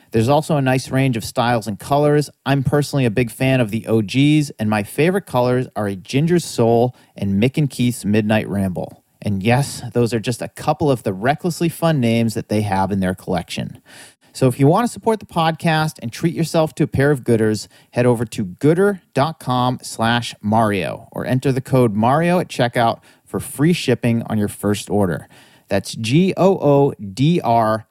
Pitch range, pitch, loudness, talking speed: 115-150 Hz, 125 Hz, -18 LUFS, 185 wpm